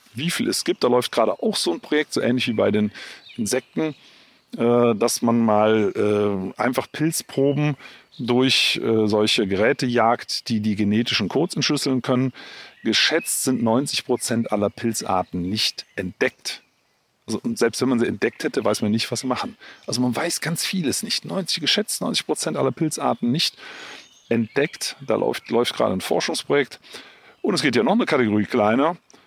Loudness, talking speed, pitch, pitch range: -21 LUFS, 165 wpm, 120 Hz, 110-145 Hz